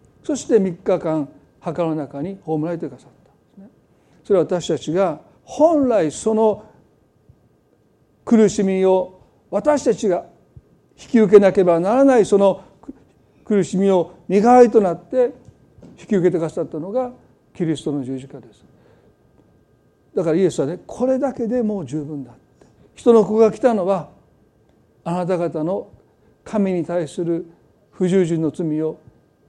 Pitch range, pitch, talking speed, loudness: 155-215 Hz, 185 Hz, 260 characters per minute, -19 LUFS